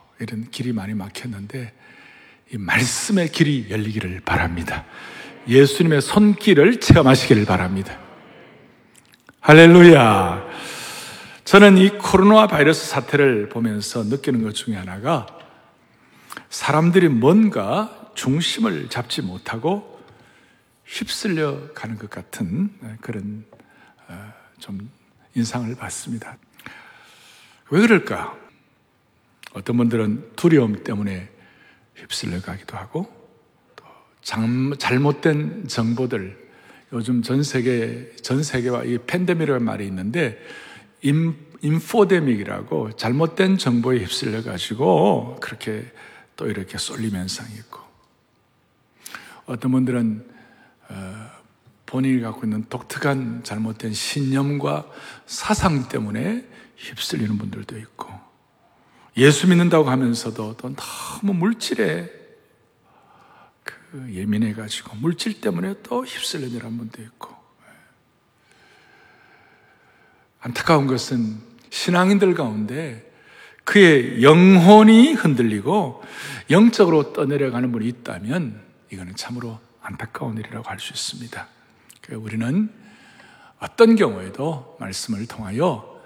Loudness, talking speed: -18 LUFS, 230 characters per minute